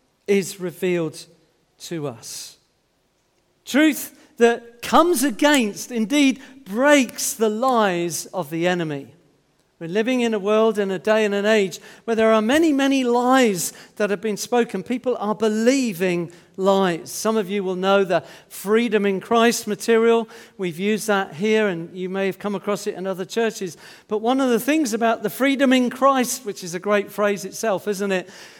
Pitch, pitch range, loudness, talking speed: 210 Hz, 190-235 Hz, -20 LUFS, 180 wpm